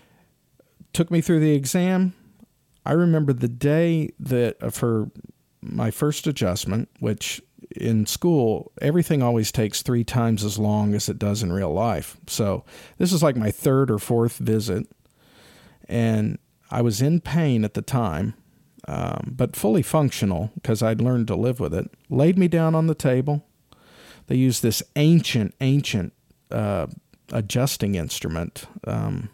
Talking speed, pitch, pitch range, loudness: 150 wpm, 125 Hz, 110-150 Hz, -23 LUFS